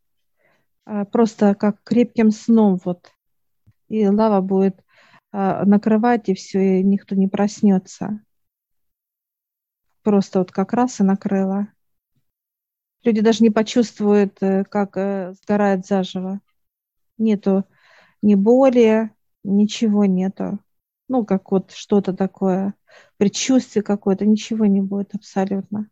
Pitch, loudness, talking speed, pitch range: 200 Hz, -19 LUFS, 100 wpm, 195-215 Hz